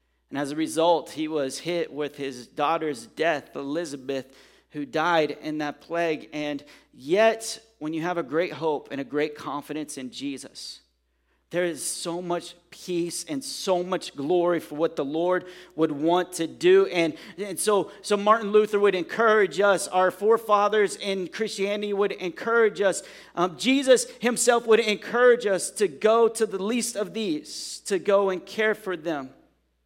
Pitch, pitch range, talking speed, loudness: 180 Hz, 155-205 Hz, 165 wpm, -25 LUFS